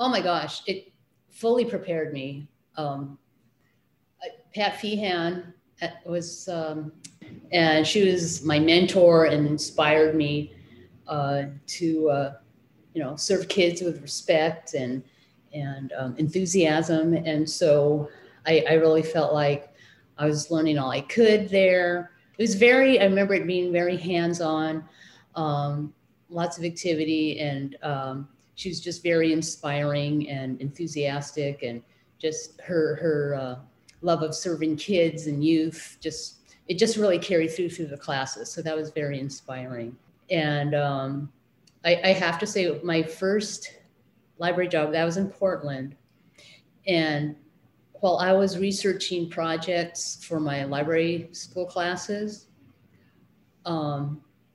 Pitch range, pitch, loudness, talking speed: 145-175 Hz, 160 Hz, -25 LUFS, 135 wpm